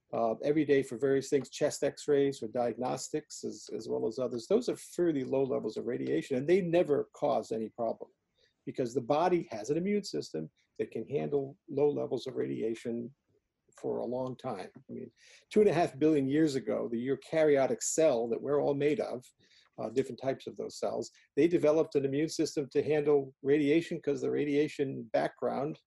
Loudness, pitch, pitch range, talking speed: -32 LUFS, 140 Hz, 130-150 Hz, 190 wpm